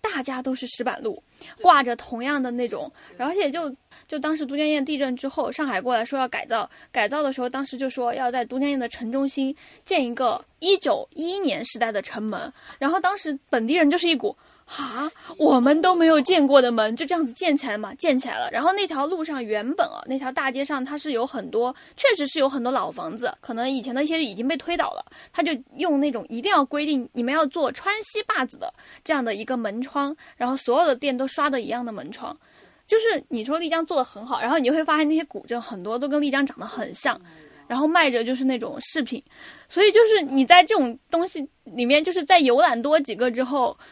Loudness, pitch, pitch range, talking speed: -23 LUFS, 280 Hz, 250-320 Hz, 330 characters per minute